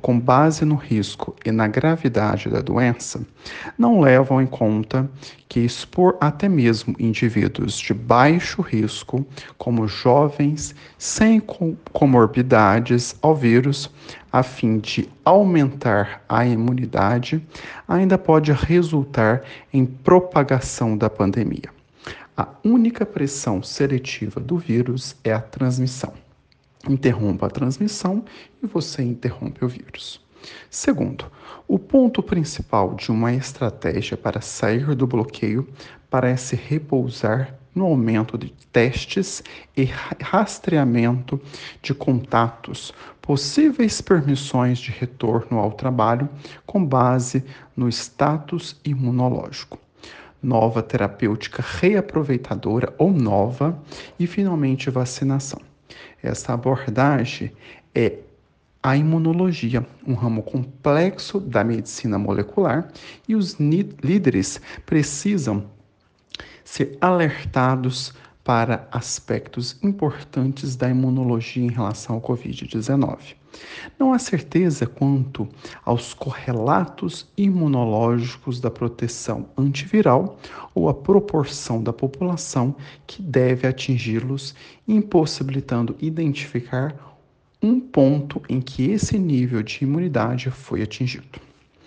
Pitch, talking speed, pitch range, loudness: 130 Hz, 100 wpm, 120-150 Hz, -21 LUFS